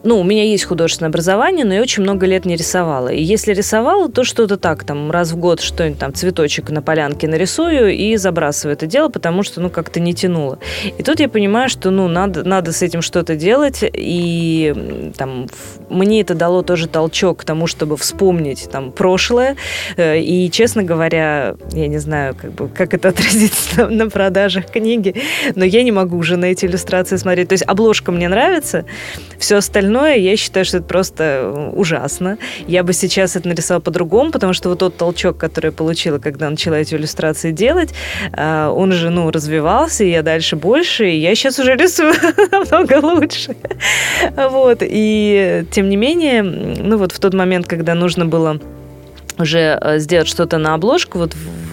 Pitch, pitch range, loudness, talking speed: 180 Hz, 165-210 Hz, -14 LUFS, 180 wpm